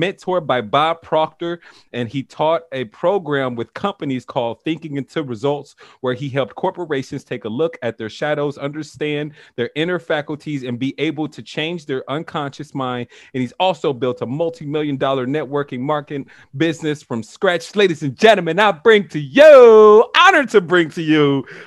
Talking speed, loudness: 165 wpm, -17 LUFS